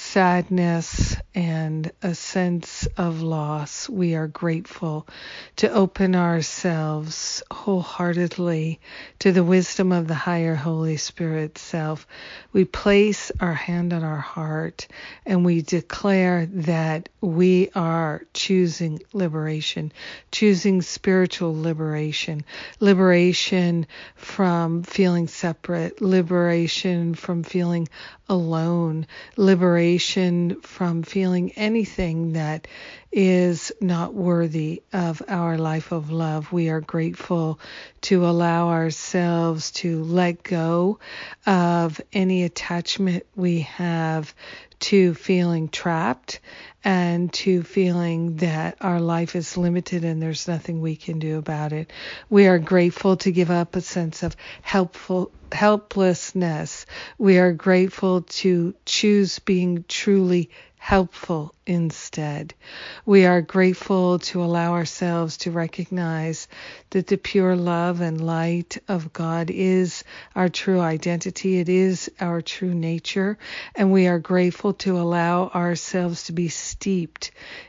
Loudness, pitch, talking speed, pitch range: -22 LUFS, 175 Hz, 115 wpm, 165-185 Hz